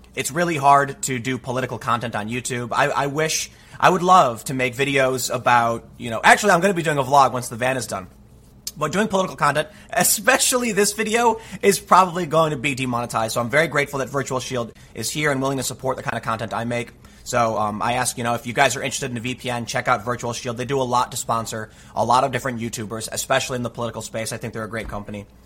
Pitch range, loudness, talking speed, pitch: 120-145 Hz, -21 LUFS, 250 wpm, 130 Hz